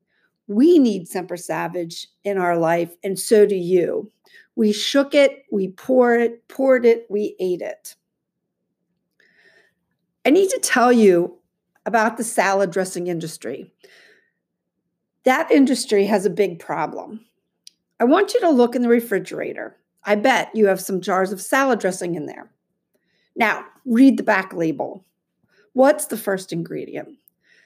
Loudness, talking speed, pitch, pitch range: -19 LUFS, 145 wpm, 215 Hz, 190-270 Hz